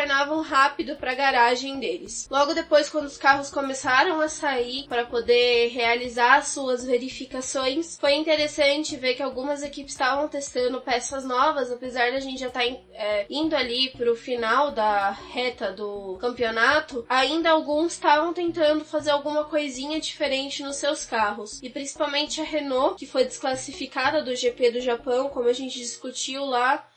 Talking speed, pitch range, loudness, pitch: 160 wpm, 245-290 Hz, -24 LUFS, 270 Hz